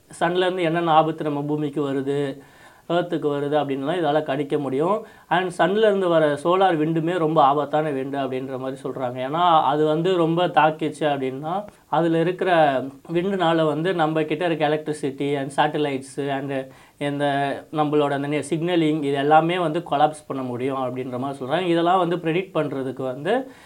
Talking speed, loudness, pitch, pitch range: 145 wpm, -22 LUFS, 150 Hz, 140-170 Hz